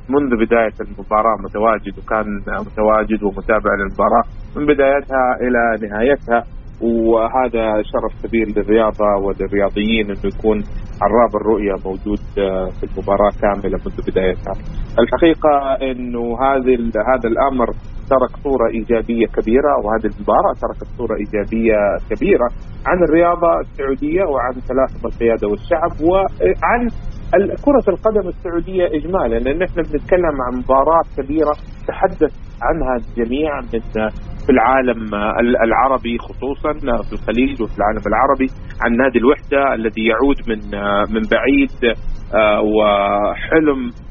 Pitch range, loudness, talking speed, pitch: 105-135 Hz, -17 LUFS, 110 wpm, 115 Hz